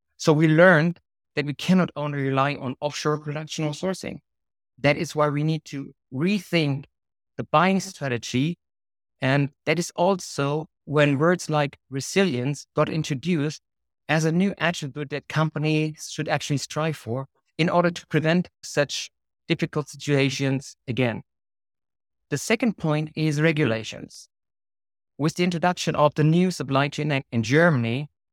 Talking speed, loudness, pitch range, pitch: 140 wpm, -24 LUFS, 140-160 Hz, 150 Hz